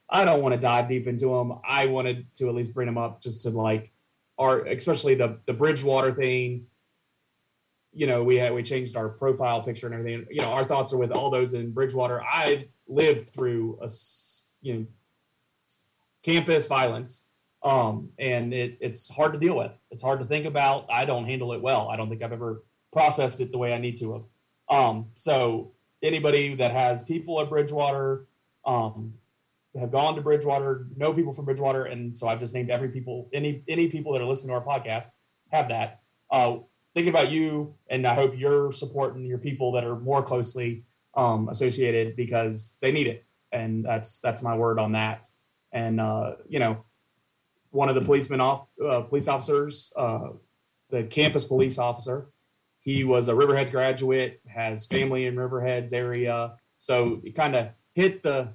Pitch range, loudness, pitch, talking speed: 120-140 Hz, -26 LUFS, 125 Hz, 185 wpm